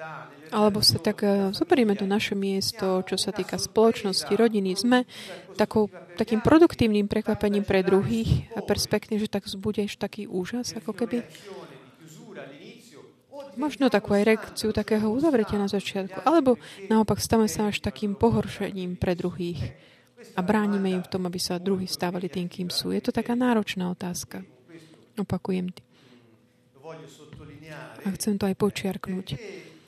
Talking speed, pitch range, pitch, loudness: 135 wpm, 180-215 Hz, 200 Hz, -25 LUFS